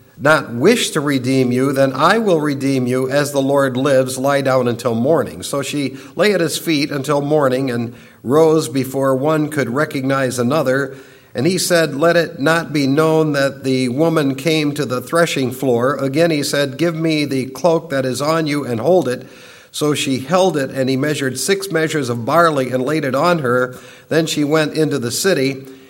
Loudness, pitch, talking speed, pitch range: -16 LUFS, 140 Hz, 195 wpm, 130-160 Hz